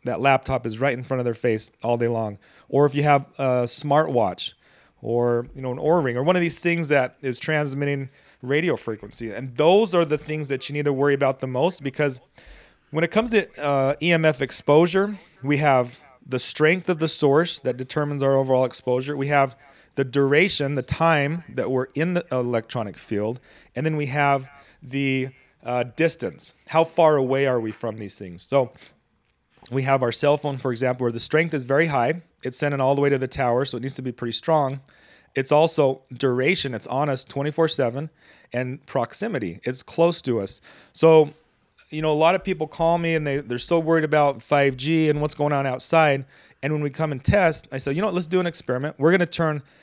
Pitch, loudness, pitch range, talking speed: 140 Hz, -22 LUFS, 130-155 Hz, 210 wpm